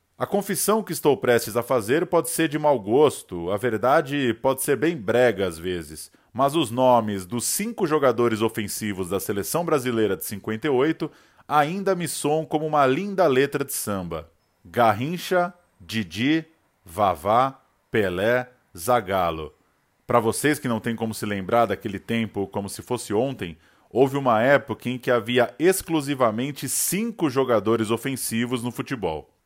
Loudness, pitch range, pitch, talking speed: -23 LUFS, 110-150 Hz, 125 Hz, 145 wpm